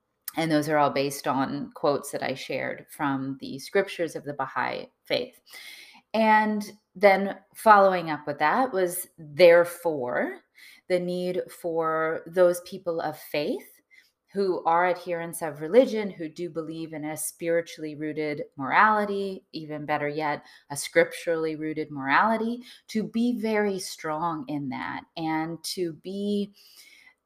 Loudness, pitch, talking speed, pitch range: -26 LUFS, 170 Hz, 135 wpm, 155-200 Hz